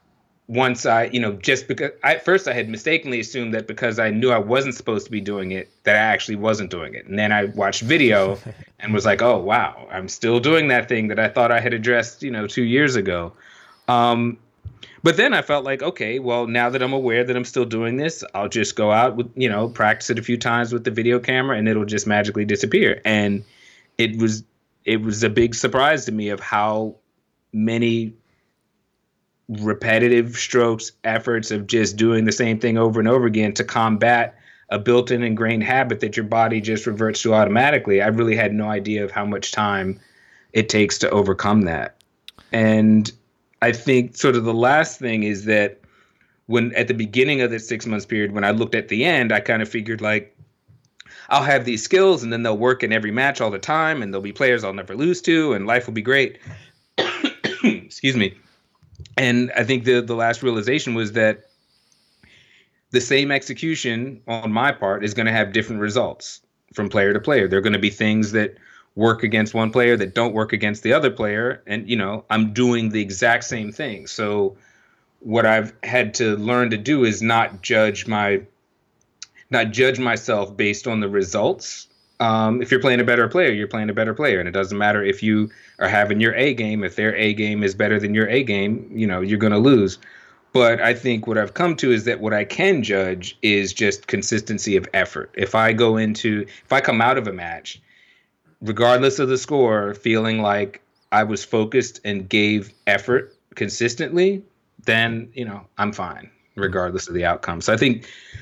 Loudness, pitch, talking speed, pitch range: -19 LUFS, 115 Hz, 205 wpm, 105-120 Hz